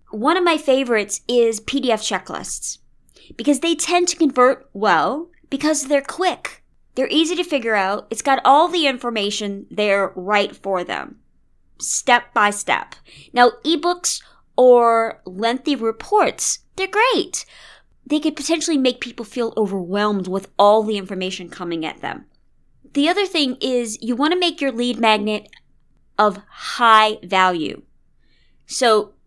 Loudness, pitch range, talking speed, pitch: -19 LUFS, 210-310 Hz, 140 wpm, 245 Hz